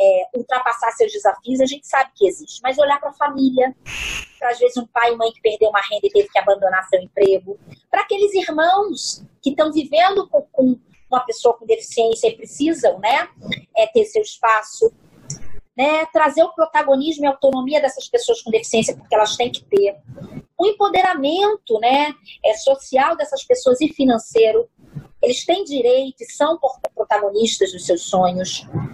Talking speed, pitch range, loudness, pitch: 170 wpm, 220-315 Hz, -18 LUFS, 260 Hz